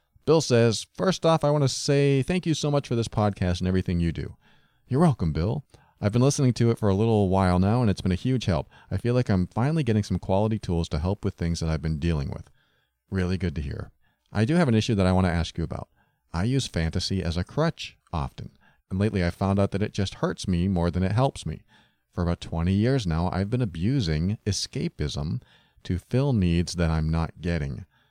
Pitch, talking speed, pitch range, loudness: 95 Hz, 235 wpm, 85-120 Hz, -25 LUFS